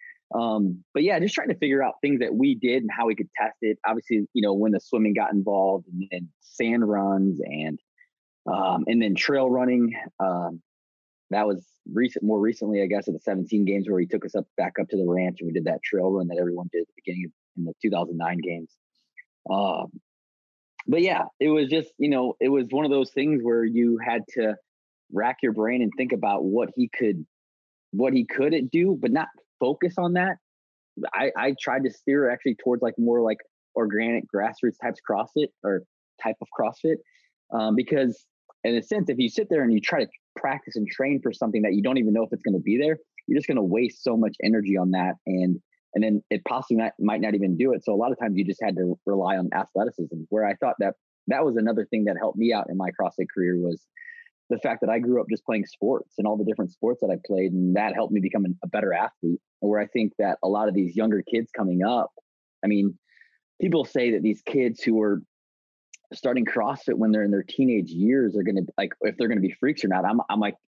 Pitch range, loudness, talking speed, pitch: 95-125 Hz, -25 LUFS, 235 wpm, 105 Hz